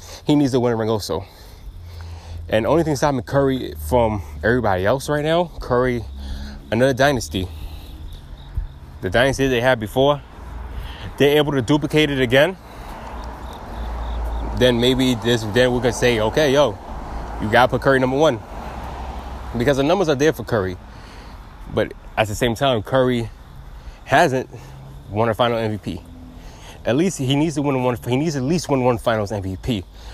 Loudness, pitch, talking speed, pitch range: -19 LUFS, 110 Hz, 155 wpm, 80-130 Hz